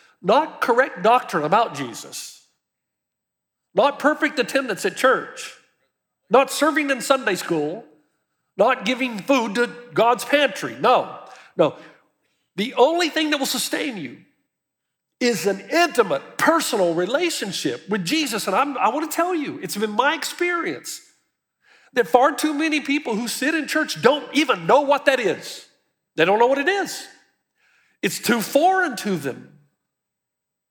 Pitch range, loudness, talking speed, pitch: 210-305 Hz, -20 LUFS, 145 wpm, 260 Hz